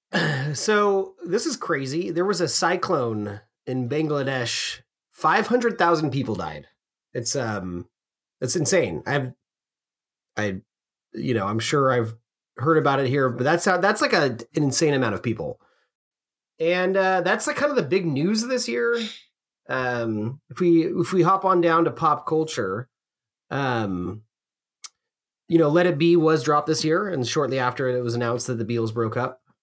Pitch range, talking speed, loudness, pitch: 120-175 Hz, 170 wpm, -23 LUFS, 145 Hz